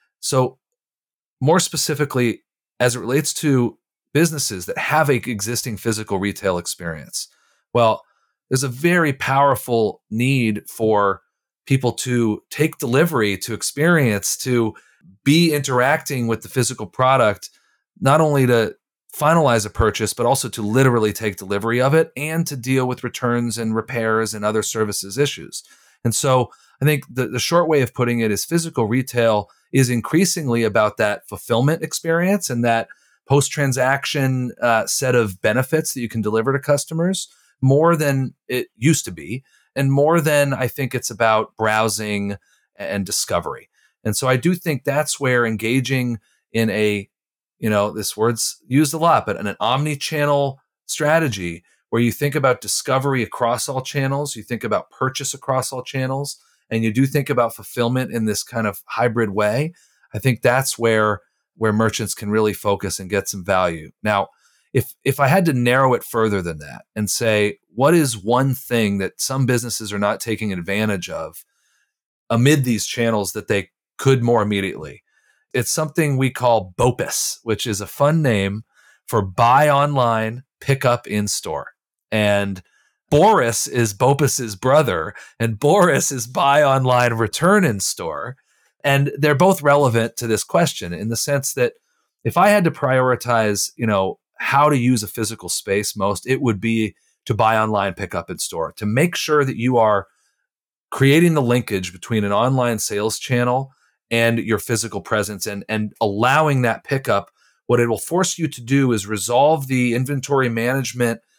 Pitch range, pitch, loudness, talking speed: 110-140 Hz, 120 Hz, -19 LUFS, 165 wpm